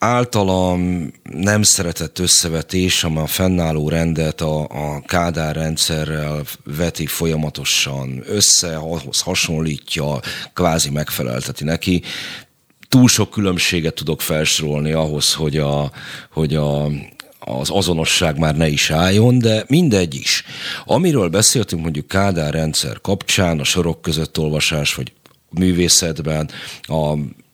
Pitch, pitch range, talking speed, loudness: 80 Hz, 75-90 Hz, 115 wpm, -17 LUFS